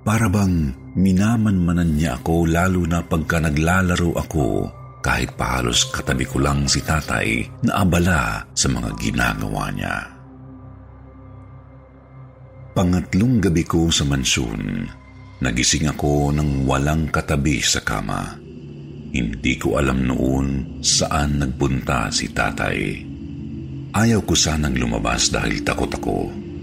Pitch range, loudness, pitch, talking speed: 70-90 Hz, -20 LUFS, 80 Hz, 115 wpm